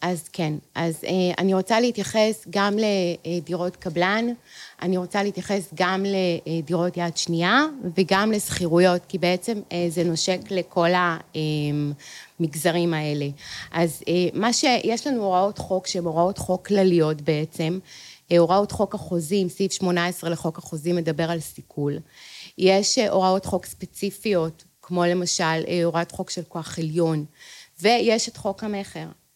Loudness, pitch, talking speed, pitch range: -23 LUFS, 180 Hz, 125 wpm, 170-195 Hz